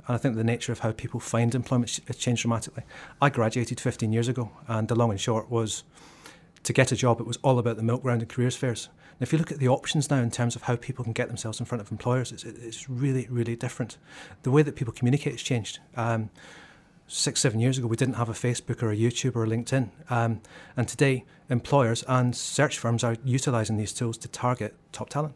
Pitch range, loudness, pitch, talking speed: 115-130 Hz, -27 LUFS, 120 Hz, 240 wpm